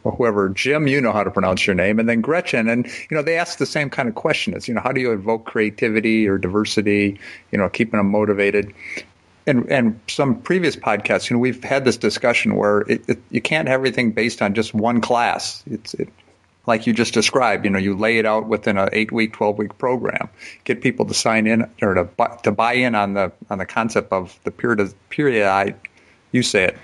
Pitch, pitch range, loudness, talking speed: 110 Hz, 105-120 Hz, -19 LUFS, 235 wpm